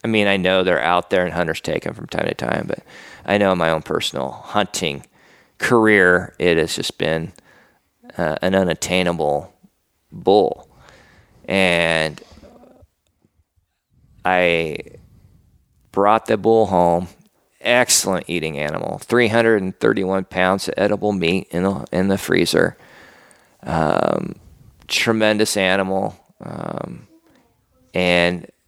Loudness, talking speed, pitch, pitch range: -18 LUFS, 125 wpm, 90 Hz, 85-100 Hz